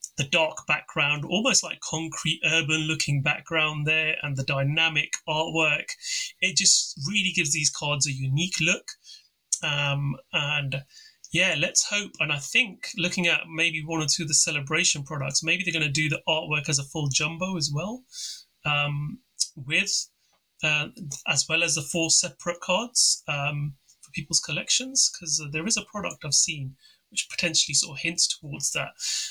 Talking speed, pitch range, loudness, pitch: 170 wpm, 150-175 Hz, -24 LUFS, 160 Hz